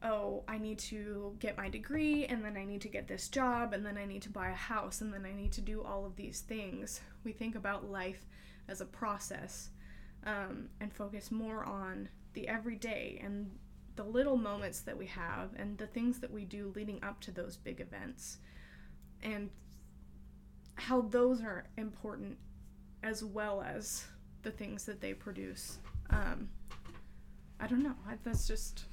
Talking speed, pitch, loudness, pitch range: 175 wpm, 210 Hz, -40 LUFS, 190-220 Hz